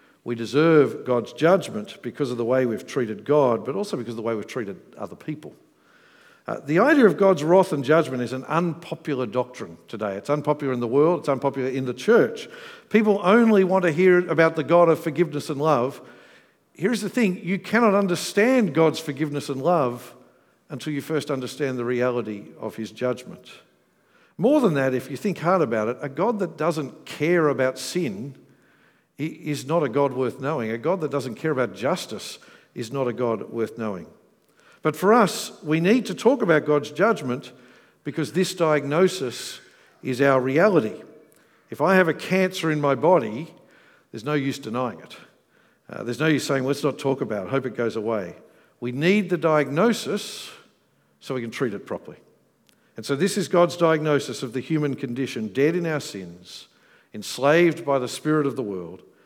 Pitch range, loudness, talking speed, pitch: 130-175 Hz, -23 LUFS, 185 wpm, 150 Hz